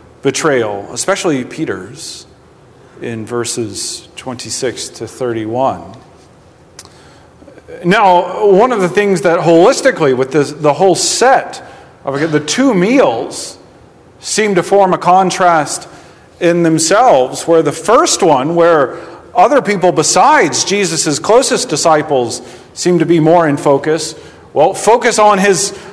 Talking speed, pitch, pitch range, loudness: 120 wpm, 170 Hz, 150-195 Hz, -11 LUFS